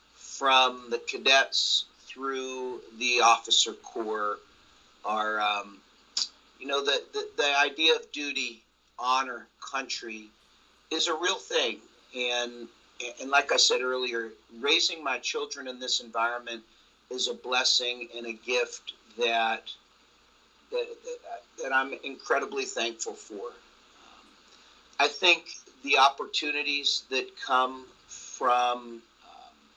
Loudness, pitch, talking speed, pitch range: -27 LUFS, 130 Hz, 115 wpm, 120-165 Hz